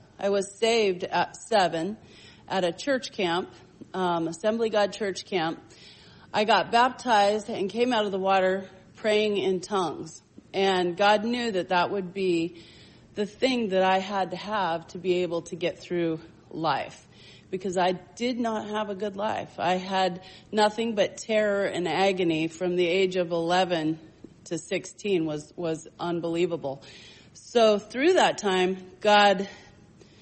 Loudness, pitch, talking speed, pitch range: -26 LUFS, 190 Hz, 155 wpm, 175-210 Hz